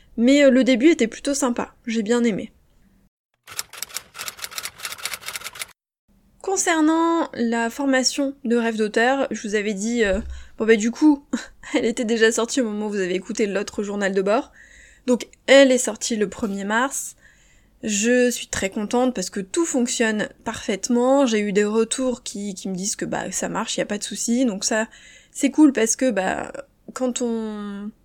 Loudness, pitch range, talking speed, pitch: -21 LUFS, 215-260 Hz, 175 wpm, 235 Hz